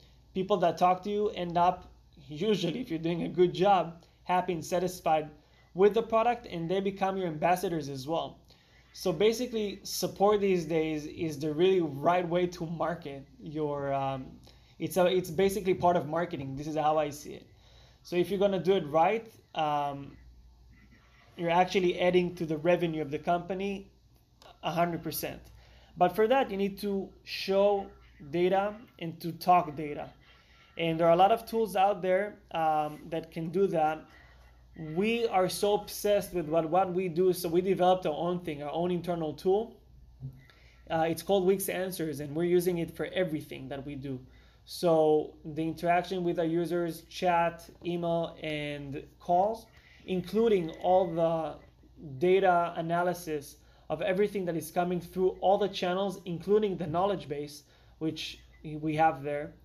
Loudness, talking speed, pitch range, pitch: -30 LUFS, 165 wpm, 155-185 Hz, 175 Hz